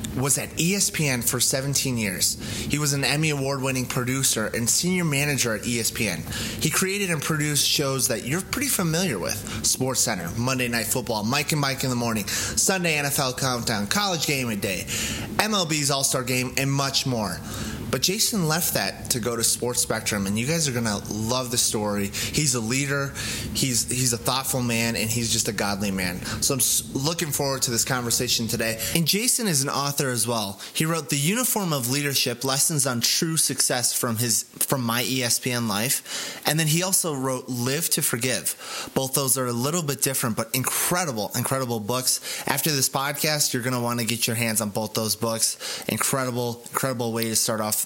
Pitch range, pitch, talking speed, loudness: 115-145 Hz, 130 Hz, 195 wpm, -23 LUFS